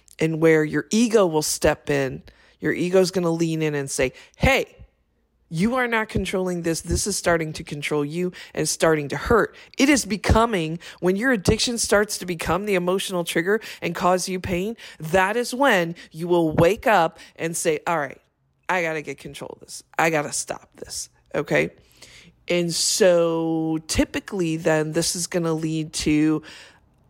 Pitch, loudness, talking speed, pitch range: 170 Hz, -22 LUFS, 175 wpm, 160-190 Hz